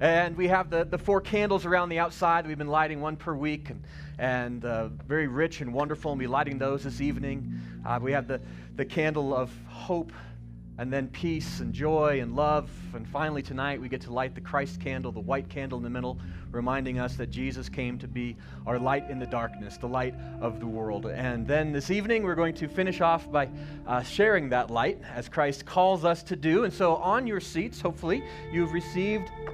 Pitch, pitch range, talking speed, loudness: 145 Hz, 120-165 Hz, 215 wpm, -29 LUFS